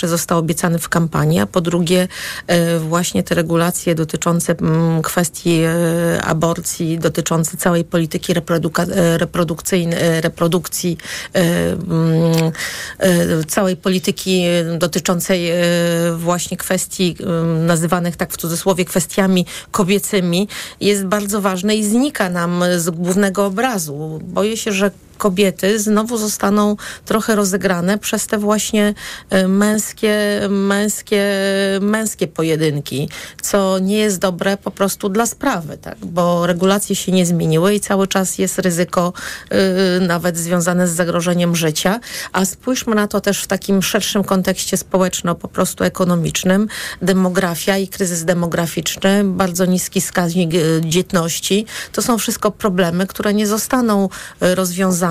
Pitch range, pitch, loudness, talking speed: 170-200 Hz, 185 Hz, -17 LUFS, 115 wpm